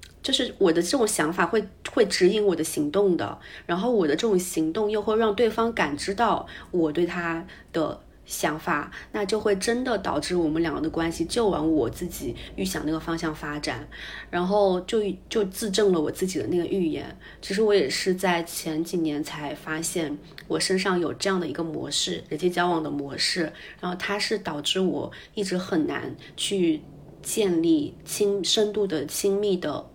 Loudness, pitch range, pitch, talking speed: -25 LUFS, 165-210 Hz, 180 Hz, 265 characters per minute